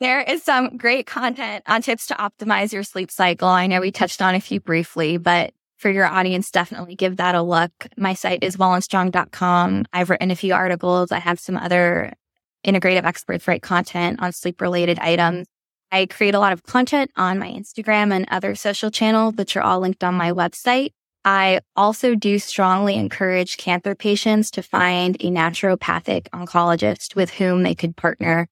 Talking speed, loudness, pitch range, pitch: 180 wpm, -19 LUFS, 180-205 Hz, 185 Hz